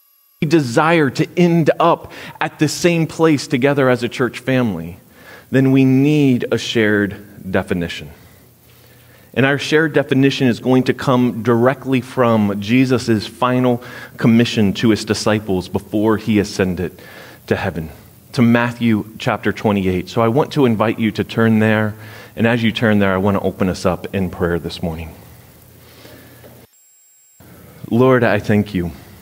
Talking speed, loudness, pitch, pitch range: 150 wpm, -16 LUFS, 115 Hz, 105-130 Hz